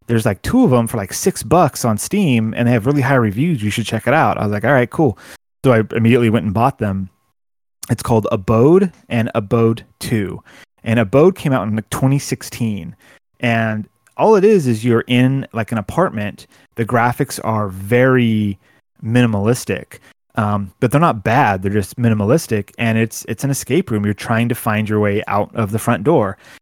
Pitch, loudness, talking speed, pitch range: 115 Hz, -16 LUFS, 195 wpm, 110-130 Hz